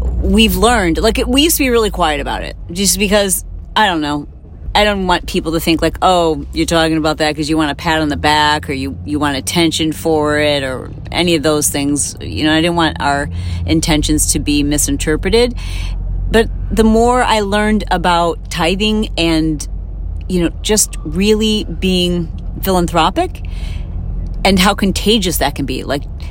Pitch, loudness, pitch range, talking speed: 160 Hz, -14 LUFS, 140-190 Hz, 180 wpm